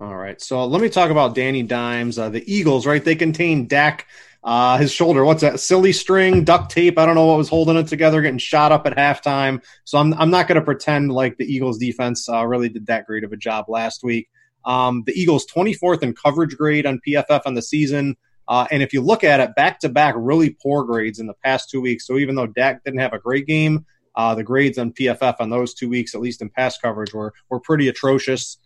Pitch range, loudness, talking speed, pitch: 120-155 Hz, -18 LUFS, 245 wpm, 135 Hz